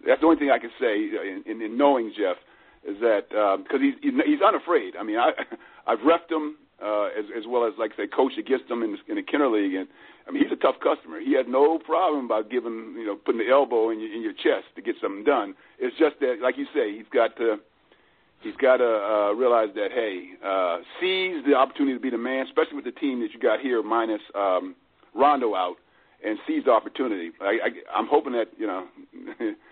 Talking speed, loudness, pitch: 220 wpm, -25 LUFS, 315 Hz